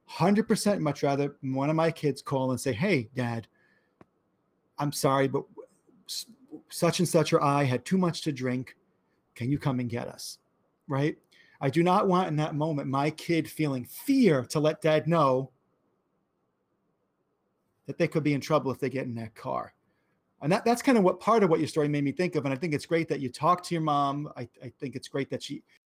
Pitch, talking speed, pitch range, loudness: 150 Hz, 215 wpm, 135-170 Hz, -28 LUFS